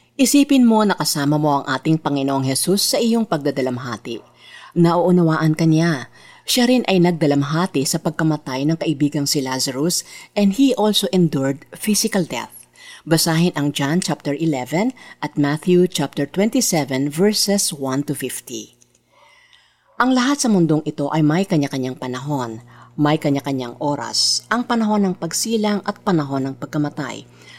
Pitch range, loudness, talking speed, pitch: 140-190 Hz, -18 LUFS, 140 wpm, 155 Hz